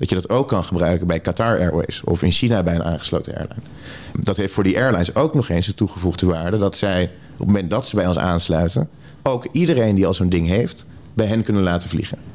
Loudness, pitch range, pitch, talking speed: -19 LUFS, 85-110 Hz, 95 Hz, 245 wpm